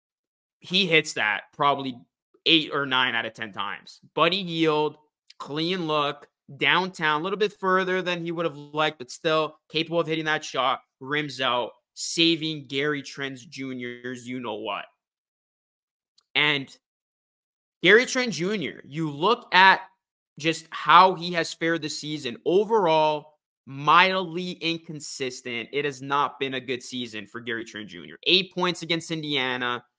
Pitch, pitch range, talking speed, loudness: 155 Hz, 135-170 Hz, 140 wpm, -24 LUFS